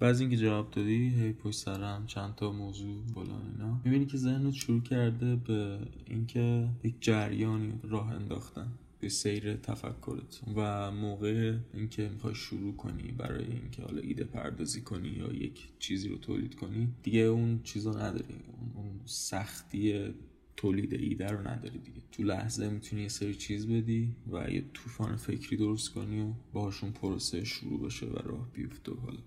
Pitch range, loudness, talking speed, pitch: 105-120 Hz, -35 LUFS, 160 wpm, 110 Hz